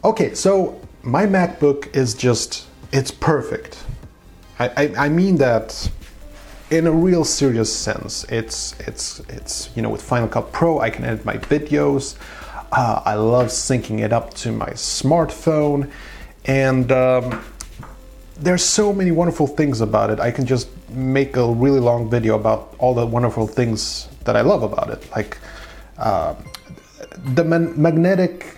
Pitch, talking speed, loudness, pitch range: 135 Hz, 155 wpm, -19 LUFS, 120-165 Hz